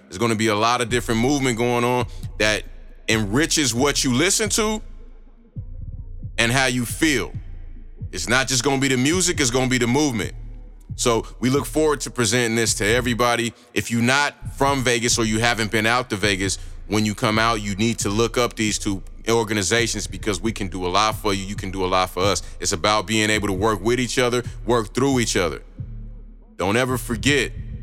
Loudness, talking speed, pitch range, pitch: -20 LUFS, 205 wpm, 105-125 Hz, 115 Hz